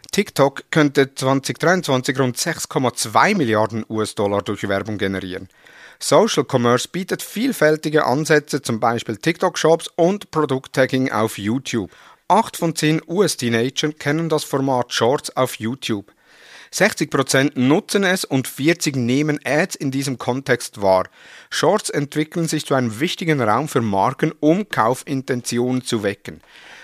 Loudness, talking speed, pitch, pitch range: -19 LUFS, 125 wpm, 135 Hz, 120-155 Hz